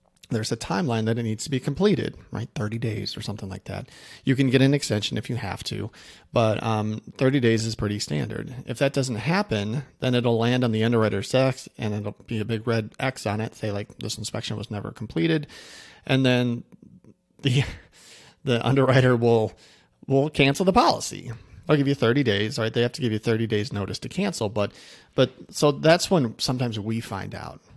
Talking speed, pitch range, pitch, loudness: 205 wpm, 105-135 Hz, 115 Hz, -24 LUFS